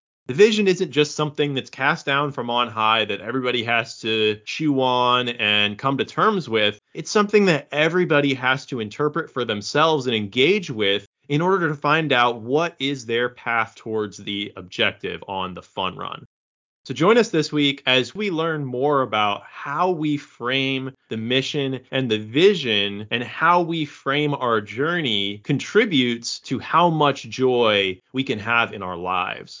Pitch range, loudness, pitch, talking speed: 110-150 Hz, -21 LUFS, 130 Hz, 170 wpm